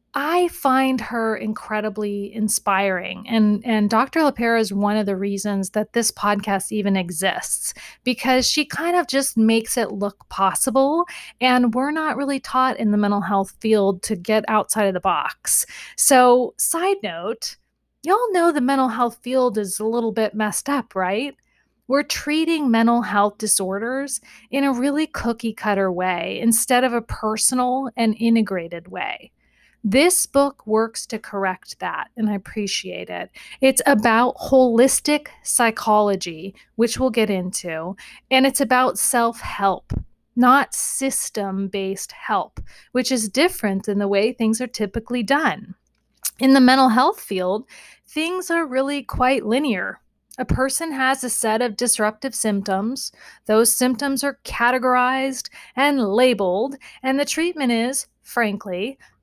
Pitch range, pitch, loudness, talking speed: 210-265 Hz, 235 Hz, -20 LUFS, 145 wpm